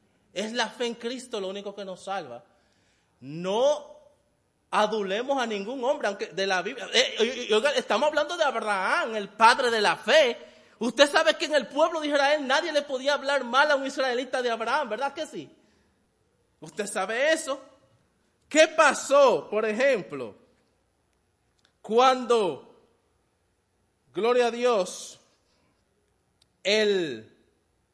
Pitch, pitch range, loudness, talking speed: 250 Hz, 210-285 Hz, -25 LUFS, 135 wpm